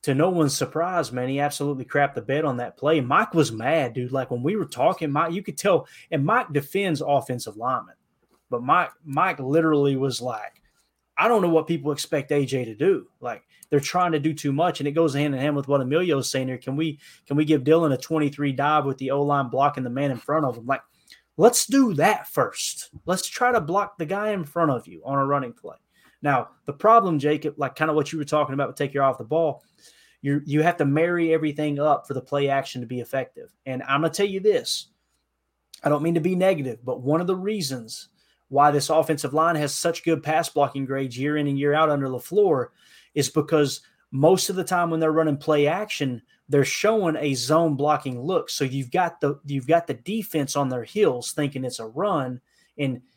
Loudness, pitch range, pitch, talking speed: -23 LUFS, 135-165 Hz, 145 Hz, 230 wpm